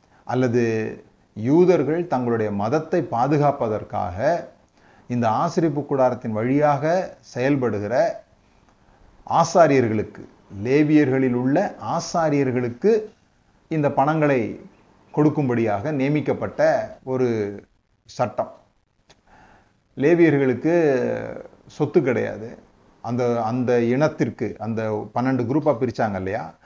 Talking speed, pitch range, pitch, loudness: 70 wpm, 120-155 Hz, 130 Hz, -21 LUFS